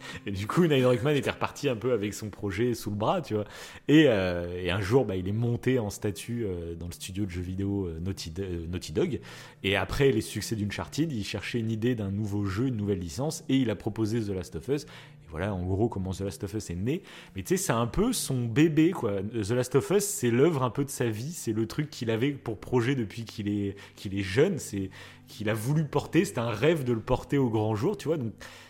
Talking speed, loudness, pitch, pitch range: 255 wpm, -29 LUFS, 110 Hz, 100-130 Hz